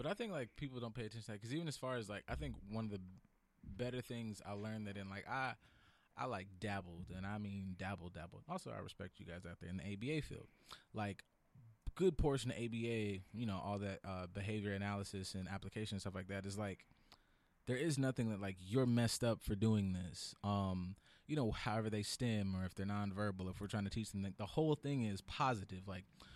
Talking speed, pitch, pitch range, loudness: 235 wpm, 100 Hz, 95-115 Hz, -43 LUFS